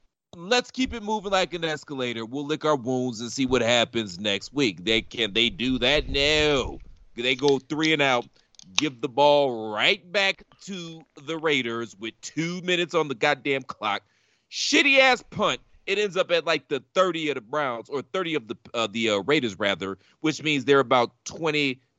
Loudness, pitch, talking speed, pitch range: -24 LUFS, 145 Hz, 195 wpm, 125-170 Hz